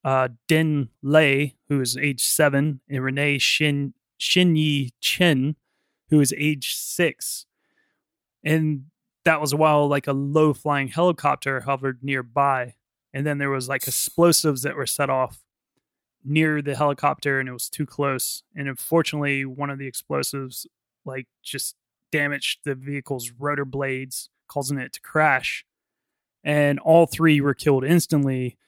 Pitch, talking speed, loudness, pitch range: 140 Hz, 140 wpm, -22 LUFS, 135-150 Hz